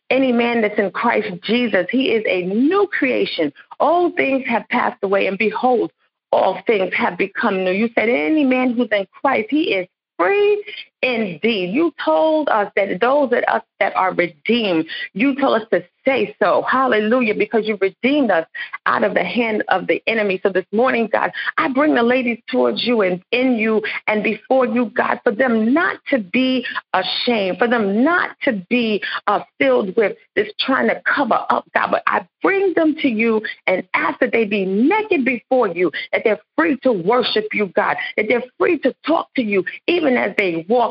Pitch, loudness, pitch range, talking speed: 245 Hz, -18 LUFS, 210-275 Hz, 190 wpm